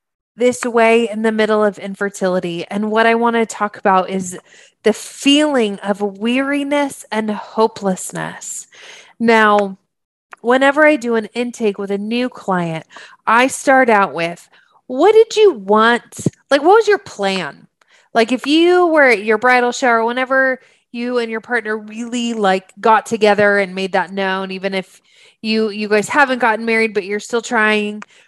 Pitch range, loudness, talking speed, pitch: 205-250 Hz, -15 LUFS, 165 wpm, 225 Hz